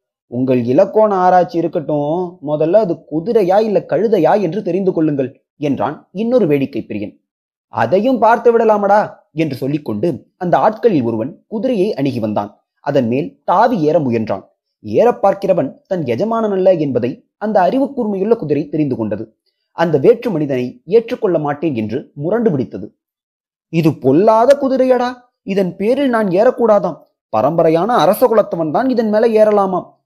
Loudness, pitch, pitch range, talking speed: -15 LUFS, 190 Hz, 150-225 Hz, 130 wpm